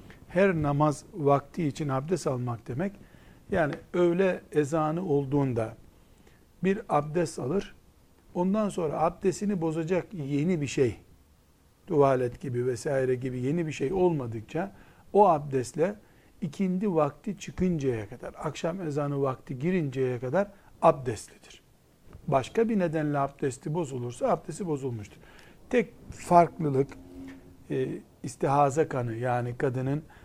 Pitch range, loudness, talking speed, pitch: 125-175 Hz, -28 LUFS, 110 wpm, 145 Hz